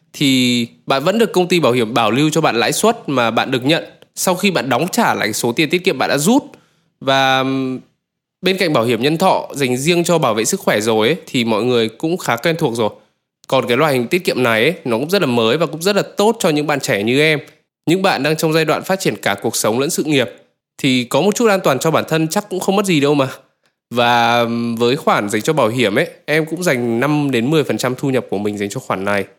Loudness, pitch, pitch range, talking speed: -16 LUFS, 150 Hz, 120-175 Hz, 270 wpm